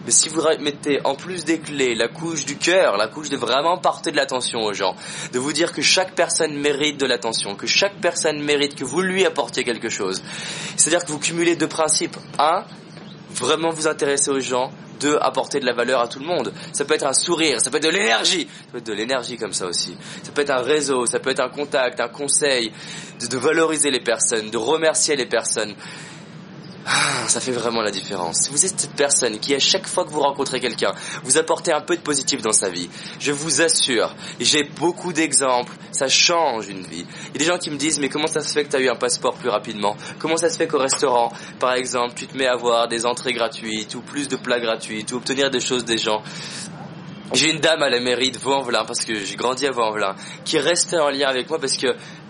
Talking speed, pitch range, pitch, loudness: 235 wpm, 125-165 Hz, 145 Hz, -20 LUFS